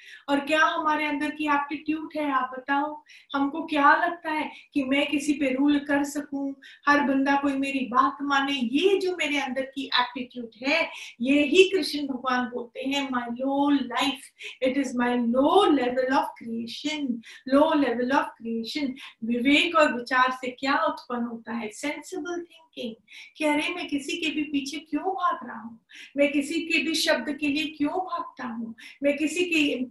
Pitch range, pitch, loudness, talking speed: 260-305 Hz, 285 Hz, -25 LUFS, 175 wpm